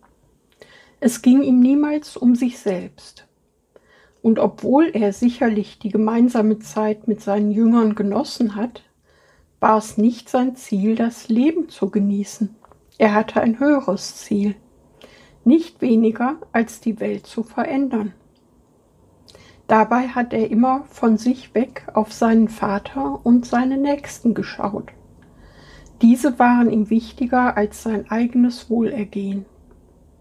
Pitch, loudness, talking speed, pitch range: 230 Hz, -19 LUFS, 125 wpm, 215-250 Hz